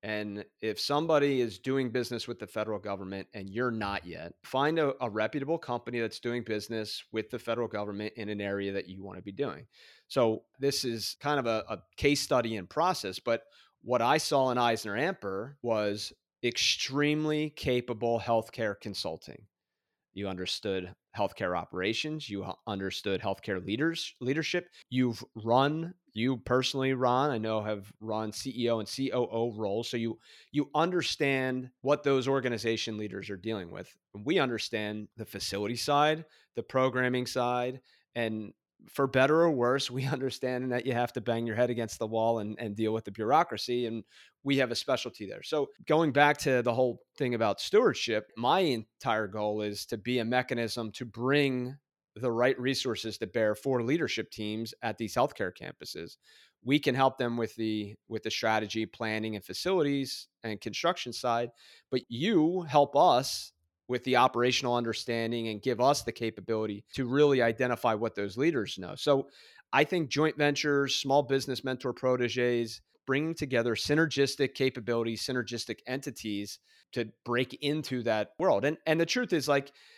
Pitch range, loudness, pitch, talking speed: 110-135 Hz, -30 LUFS, 120 Hz, 165 wpm